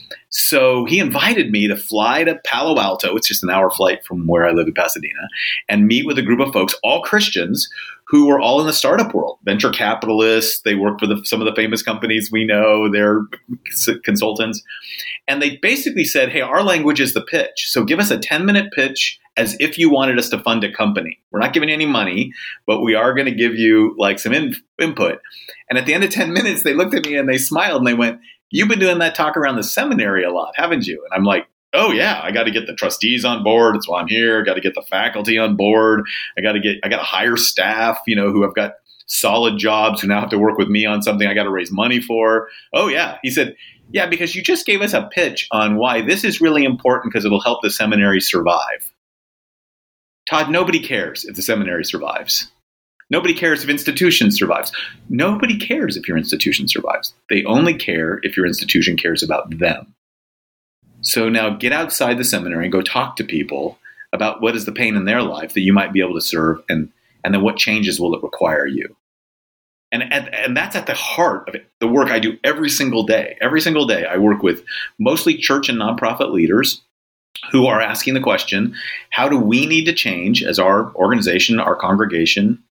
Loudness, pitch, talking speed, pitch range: -16 LUFS, 115 Hz, 220 wpm, 105-150 Hz